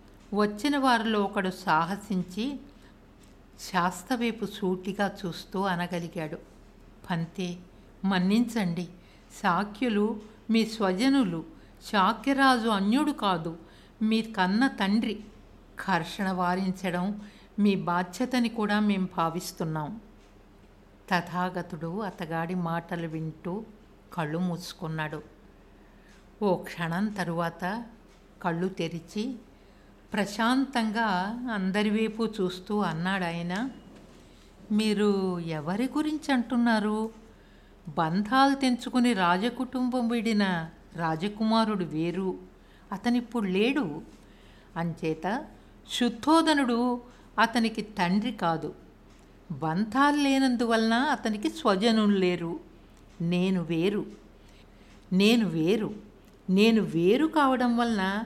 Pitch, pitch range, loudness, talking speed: 200 Hz, 175-230 Hz, -28 LUFS, 75 wpm